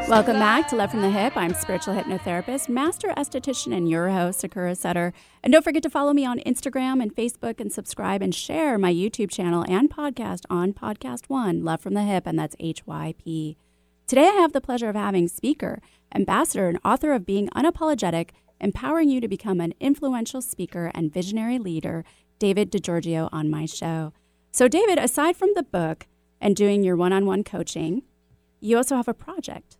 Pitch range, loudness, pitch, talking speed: 175-260 Hz, -24 LUFS, 200 Hz, 185 wpm